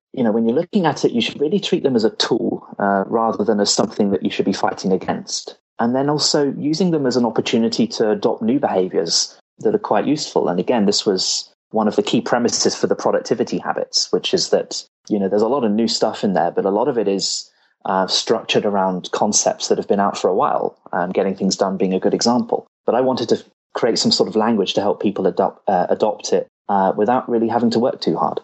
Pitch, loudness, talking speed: 120 Hz, -18 LUFS, 245 wpm